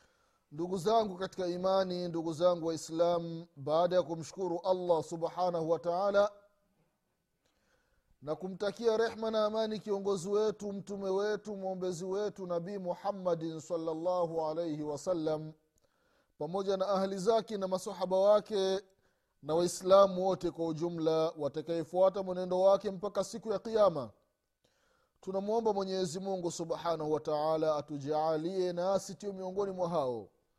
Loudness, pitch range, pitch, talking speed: -33 LUFS, 170-200 Hz, 185 Hz, 115 wpm